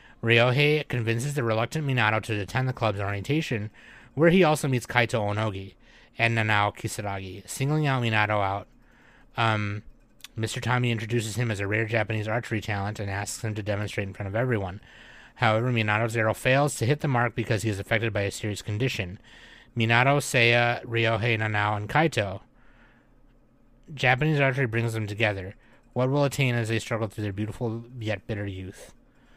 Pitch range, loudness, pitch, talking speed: 105-125 Hz, -26 LUFS, 115 Hz, 170 wpm